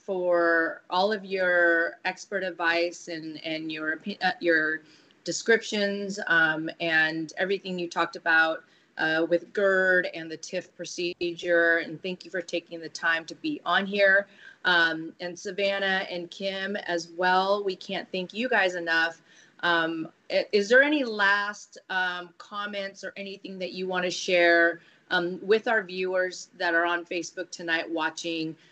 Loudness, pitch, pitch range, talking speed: -26 LUFS, 180 Hz, 165-195 Hz, 155 wpm